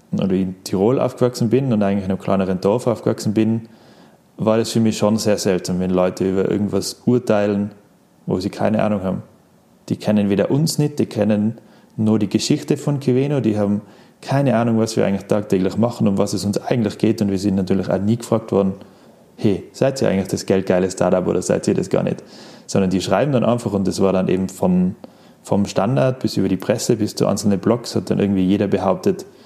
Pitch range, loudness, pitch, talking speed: 95-115 Hz, -19 LUFS, 105 Hz, 215 wpm